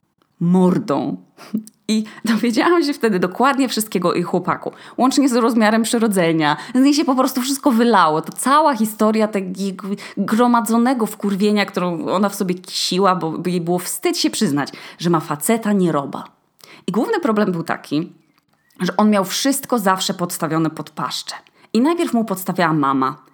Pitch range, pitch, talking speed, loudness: 175-235 Hz, 200 Hz, 155 wpm, -18 LUFS